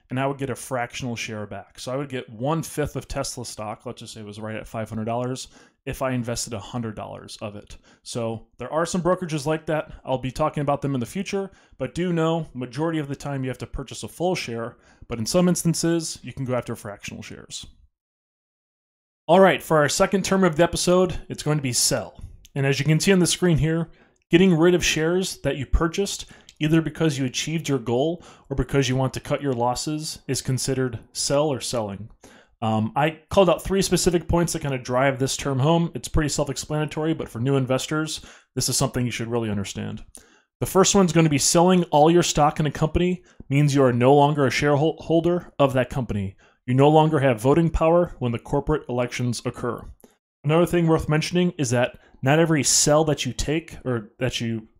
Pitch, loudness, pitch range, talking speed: 140 Hz, -22 LUFS, 120-160 Hz, 220 wpm